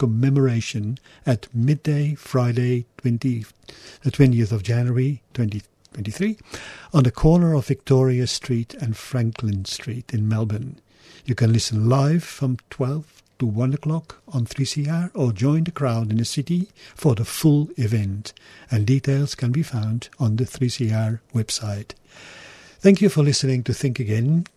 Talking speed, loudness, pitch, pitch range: 145 wpm, -22 LUFS, 125 Hz, 115-140 Hz